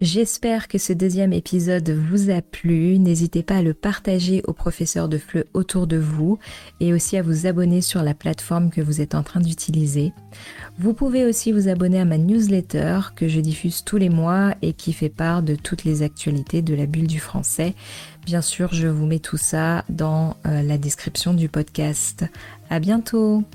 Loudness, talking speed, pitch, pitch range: -21 LUFS, 190 wpm, 170 Hz, 155-190 Hz